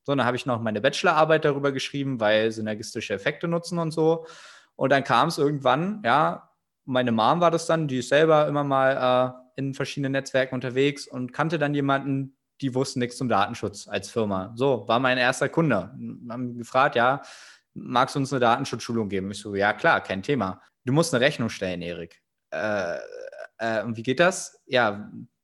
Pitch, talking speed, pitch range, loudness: 130 Hz, 190 wpm, 115-145 Hz, -24 LUFS